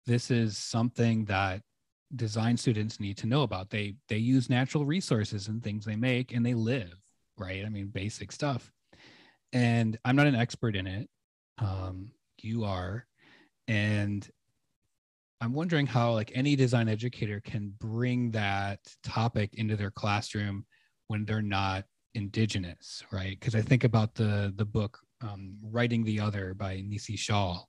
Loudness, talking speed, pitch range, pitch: -31 LUFS, 155 wpm, 100-120 Hz, 110 Hz